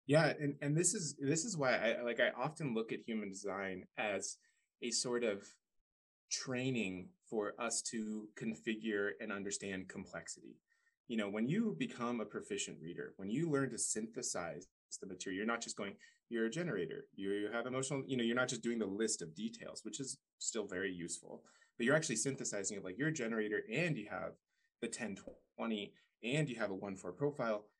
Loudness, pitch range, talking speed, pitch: -40 LUFS, 105-140 Hz, 190 wpm, 115 Hz